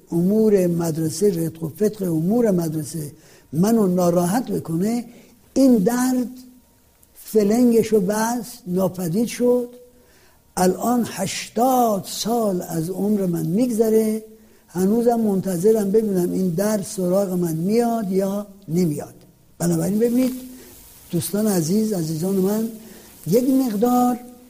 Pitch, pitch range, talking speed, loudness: 210 Hz, 180-235 Hz, 105 wpm, -20 LUFS